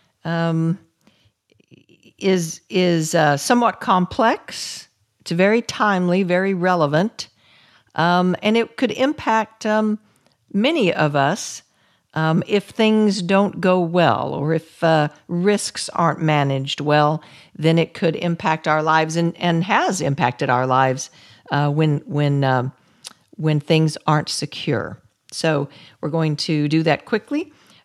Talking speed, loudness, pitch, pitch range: 130 wpm, -19 LUFS, 165 Hz, 150-190 Hz